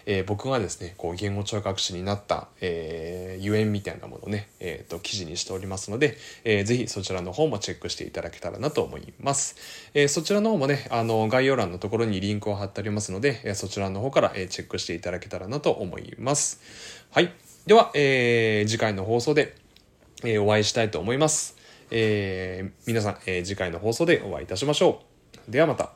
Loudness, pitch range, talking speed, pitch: -26 LUFS, 95-120 Hz, 420 characters per minute, 105 Hz